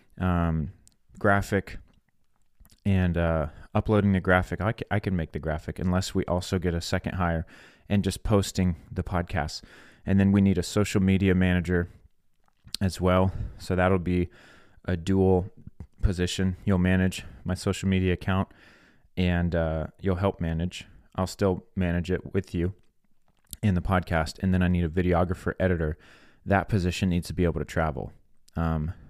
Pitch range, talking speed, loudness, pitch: 85-95 Hz, 155 wpm, -27 LUFS, 90 Hz